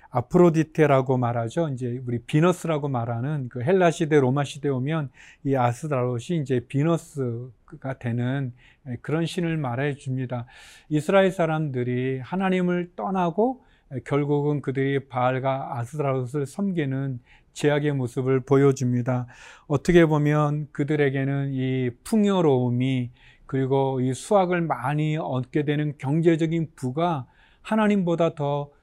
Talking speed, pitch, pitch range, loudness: 290 characters per minute, 145 Hz, 130-160 Hz, -24 LUFS